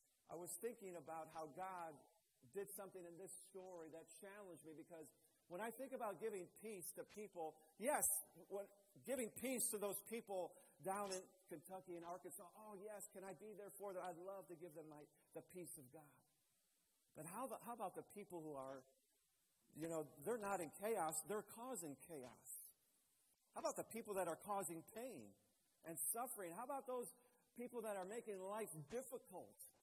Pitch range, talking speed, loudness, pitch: 165-210 Hz, 175 wpm, -51 LUFS, 190 Hz